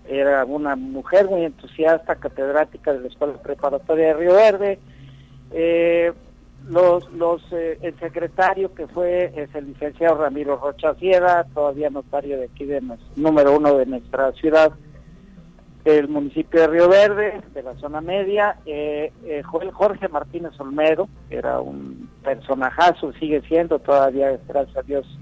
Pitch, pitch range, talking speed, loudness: 150 Hz, 140-170 Hz, 150 wpm, -20 LUFS